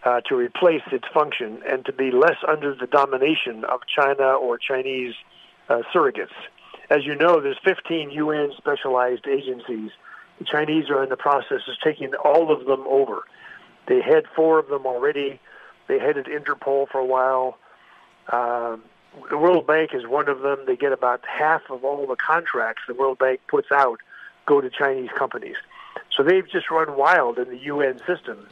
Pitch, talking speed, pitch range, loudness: 145 Hz, 175 wpm, 130-180 Hz, -22 LUFS